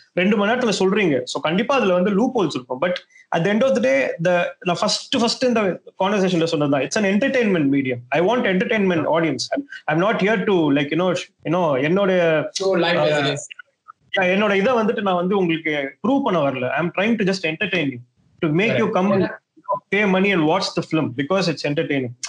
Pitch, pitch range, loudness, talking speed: 185 Hz, 160-210 Hz, -19 LUFS, 135 wpm